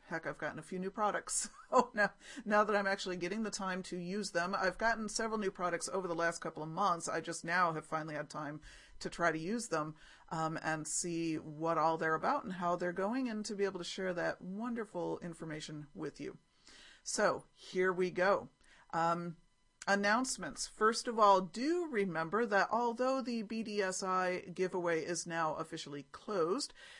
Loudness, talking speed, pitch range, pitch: -36 LUFS, 190 wpm, 165-210 Hz, 185 Hz